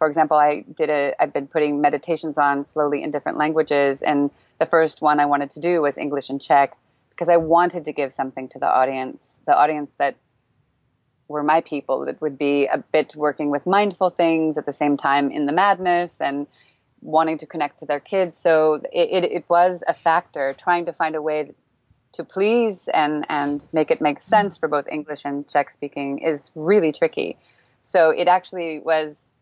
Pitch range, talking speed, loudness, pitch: 145-165 Hz, 200 wpm, -21 LUFS, 150 Hz